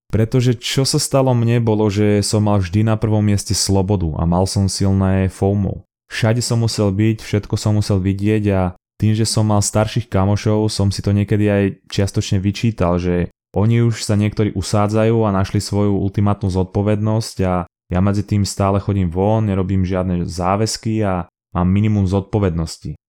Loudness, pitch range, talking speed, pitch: -17 LUFS, 95-110 Hz, 170 wpm, 105 Hz